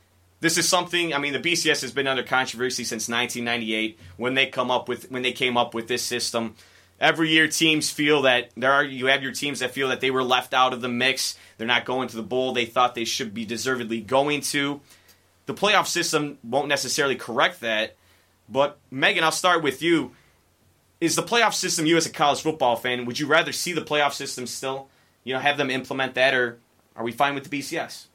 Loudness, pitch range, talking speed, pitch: -23 LUFS, 120-145 Hz, 220 wpm, 130 Hz